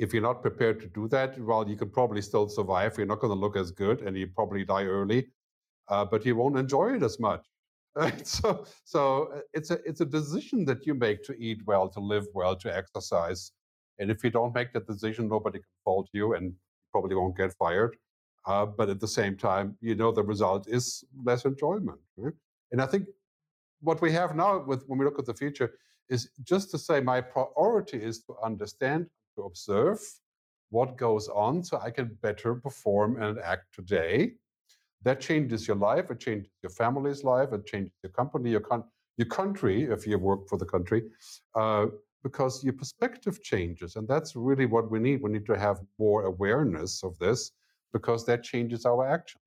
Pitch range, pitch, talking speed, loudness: 105-135 Hz, 115 Hz, 200 wpm, -29 LUFS